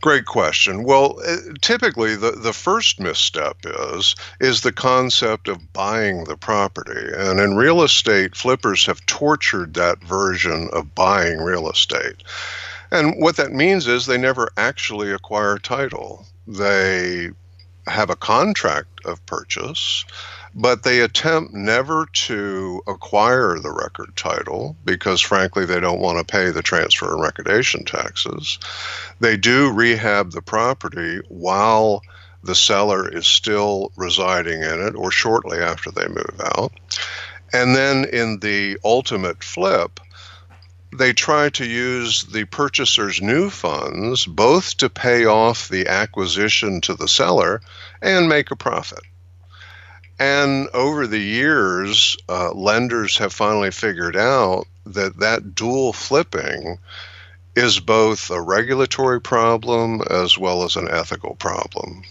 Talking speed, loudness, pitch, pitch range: 130 wpm, -18 LUFS, 105 Hz, 90-120 Hz